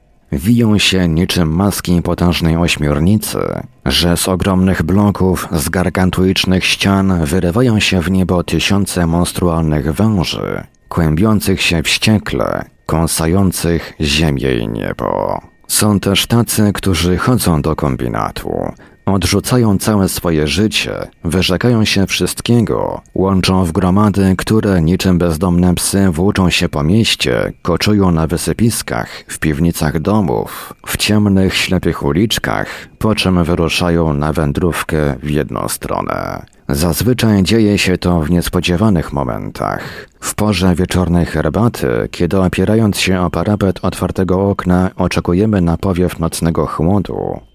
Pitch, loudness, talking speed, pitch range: 90 Hz, -14 LUFS, 120 wpm, 85-100 Hz